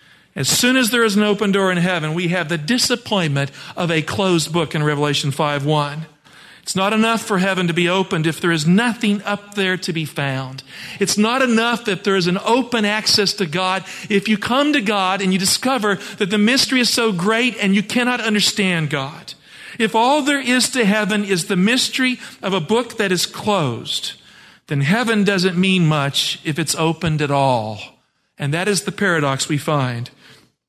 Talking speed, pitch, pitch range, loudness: 195 wpm, 195 Hz, 165-220 Hz, -17 LUFS